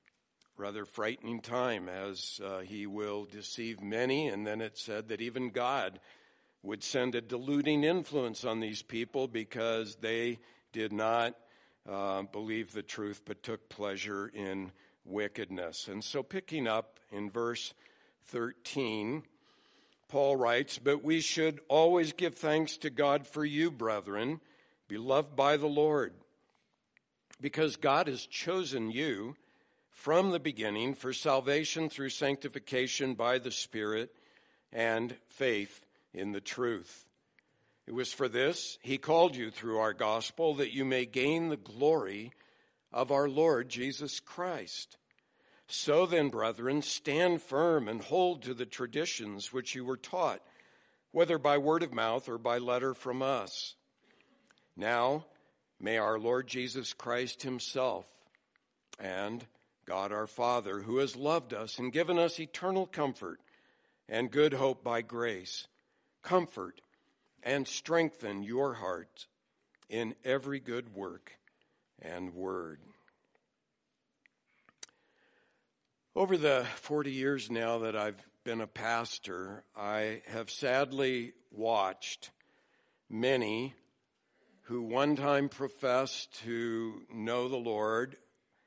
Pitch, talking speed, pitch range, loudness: 125 Hz, 125 wpm, 110-140 Hz, -34 LUFS